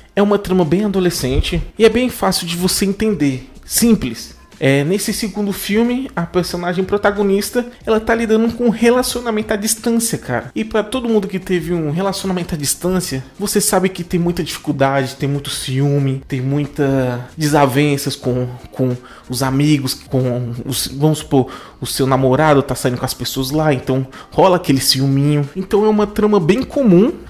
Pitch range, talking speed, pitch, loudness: 135-205 Hz, 170 wpm, 175 Hz, -16 LUFS